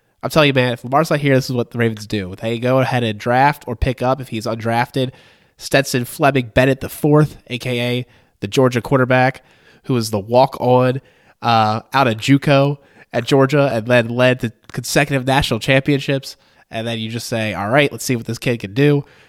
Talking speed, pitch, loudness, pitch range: 205 wpm, 125 Hz, -17 LUFS, 115-135 Hz